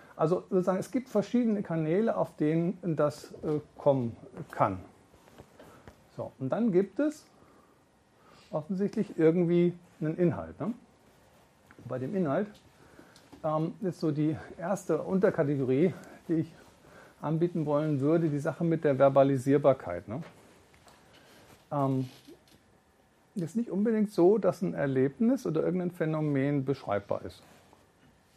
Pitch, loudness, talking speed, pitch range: 160 Hz, -29 LUFS, 115 wpm, 140-185 Hz